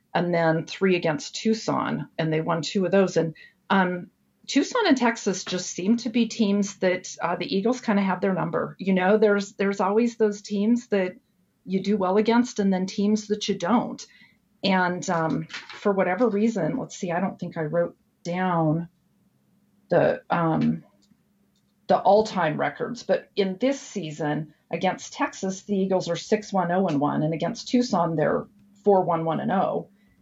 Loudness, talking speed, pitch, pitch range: -24 LUFS, 175 wpm, 195 Hz, 175-215 Hz